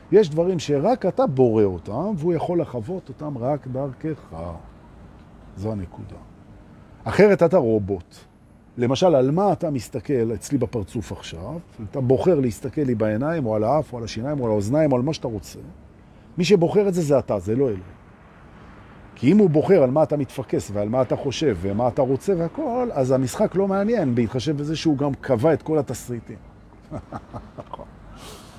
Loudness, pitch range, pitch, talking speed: -22 LUFS, 105-155 Hz, 130 Hz, 170 wpm